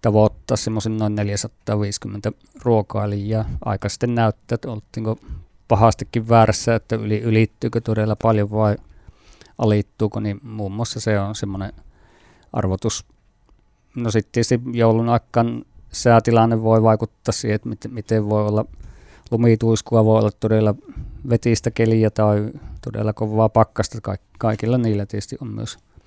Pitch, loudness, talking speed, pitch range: 110 Hz, -20 LUFS, 125 wpm, 105-115 Hz